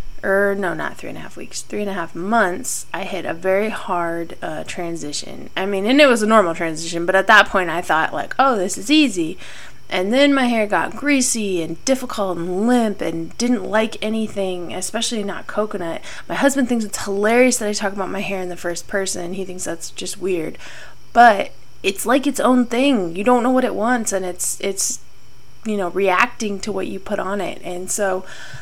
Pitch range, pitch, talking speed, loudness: 185-235 Hz, 200 Hz, 215 wpm, -19 LUFS